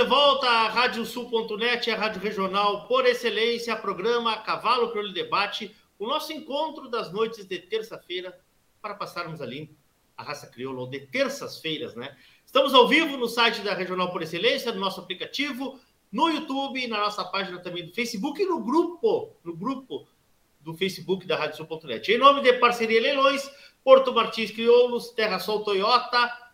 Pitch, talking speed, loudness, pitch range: 230 Hz, 165 wpm, -24 LUFS, 190-265 Hz